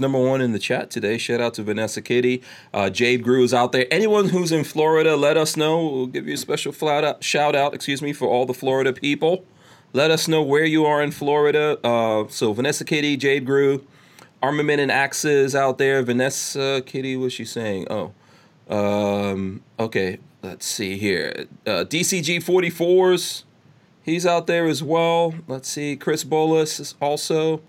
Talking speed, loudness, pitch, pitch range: 180 wpm, -21 LUFS, 140 Hz, 125-155 Hz